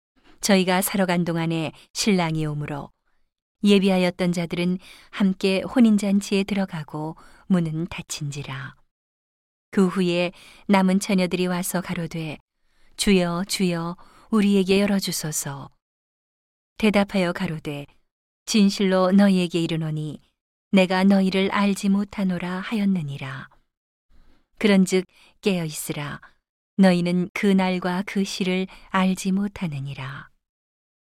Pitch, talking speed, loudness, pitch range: 185 Hz, 240 characters per minute, -22 LUFS, 165-195 Hz